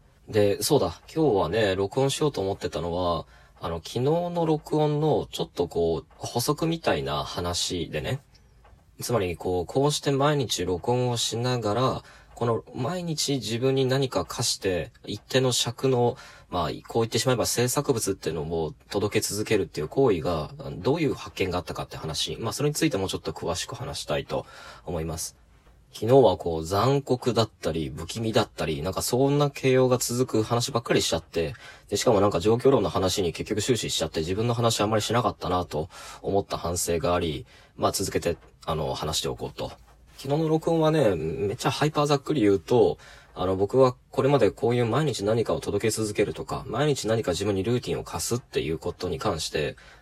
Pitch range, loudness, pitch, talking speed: 95-135 Hz, -26 LUFS, 115 Hz, 380 characters per minute